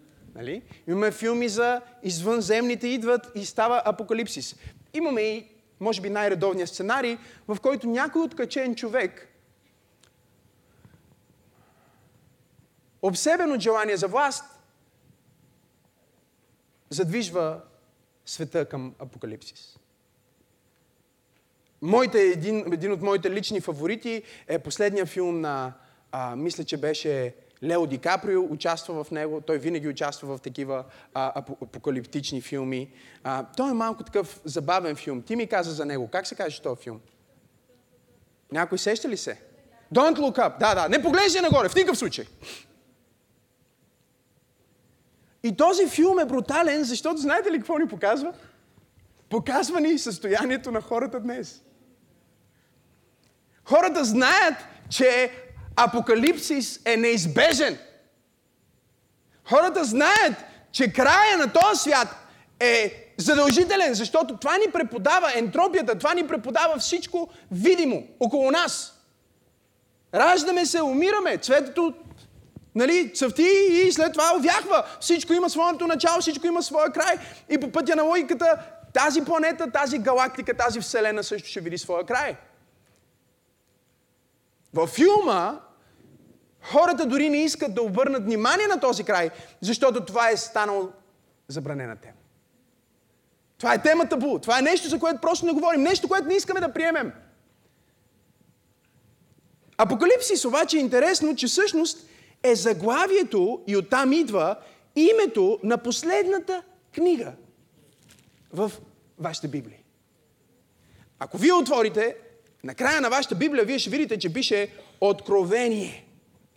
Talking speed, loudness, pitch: 120 wpm, -23 LUFS, 240 Hz